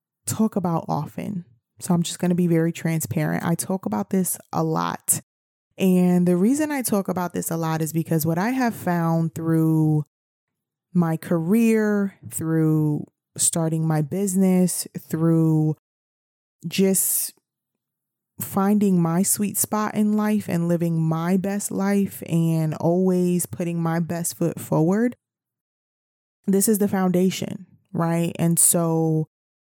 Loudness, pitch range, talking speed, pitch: -22 LUFS, 160-195 Hz, 135 wpm, 175 Hz